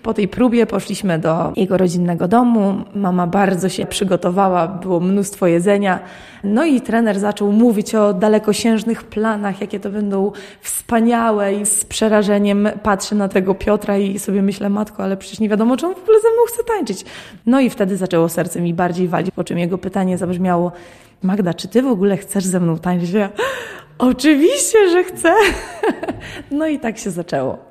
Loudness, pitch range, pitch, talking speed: -17 LUFS, 185-225 Hz, 205 Hz, 175 wpm